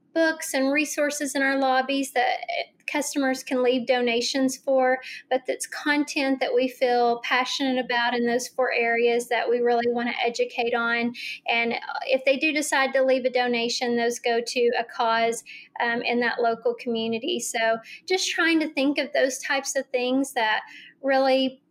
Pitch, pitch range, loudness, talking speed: 255 Hz, 240-270 Hz, -24 LUFS, 170 wpm